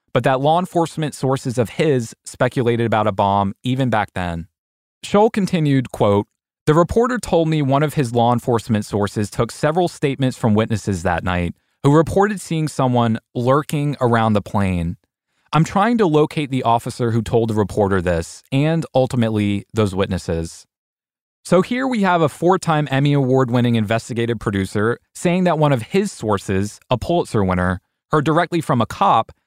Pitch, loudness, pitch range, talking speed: 125 Hz, -18 LUFS, 105-155 Hz, 165 wpm